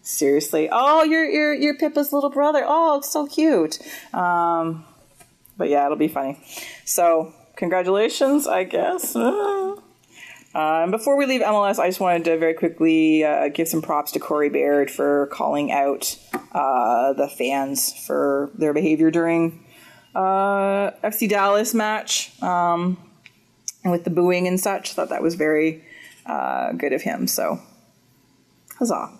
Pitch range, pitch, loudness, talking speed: 155-220 Hz, 175 Hz, -21 LUFS, 145 wpm